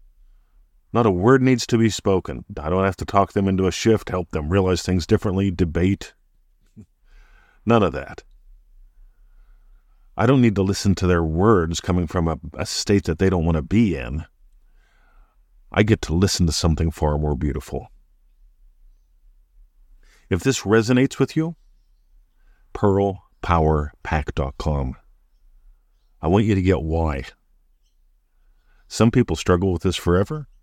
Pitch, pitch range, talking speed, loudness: 90 Hz, 75-100 Hz, 140 wpm, -21 LUFS